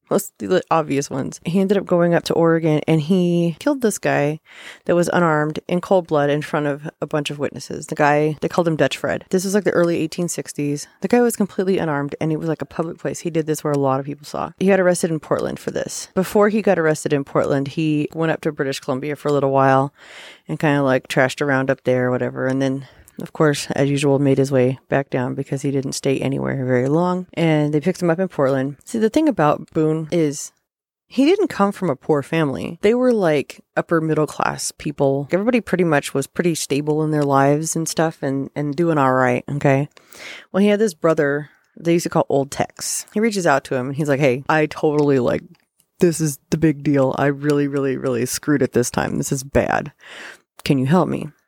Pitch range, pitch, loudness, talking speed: 140-170 Hz, 150 Hz, -19 LUFS, 235 wpm